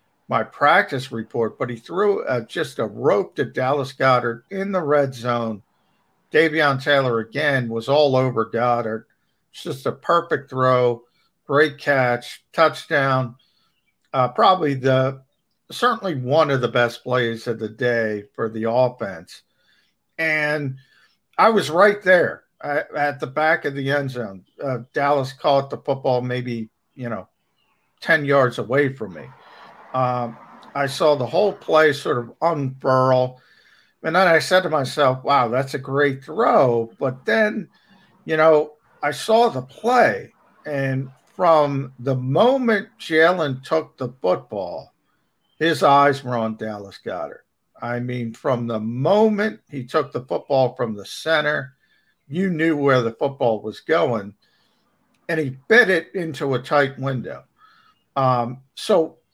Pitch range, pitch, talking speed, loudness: 125-160 Hz, 135 Hz, 145 wpm, -20 LUFS